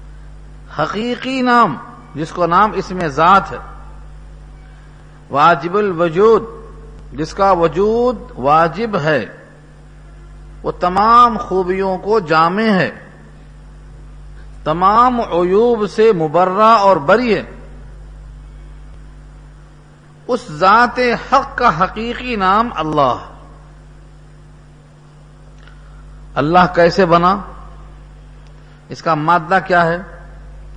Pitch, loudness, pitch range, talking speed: 175 Hz, -14 LUFS, 150-215 Hz, 85 wpm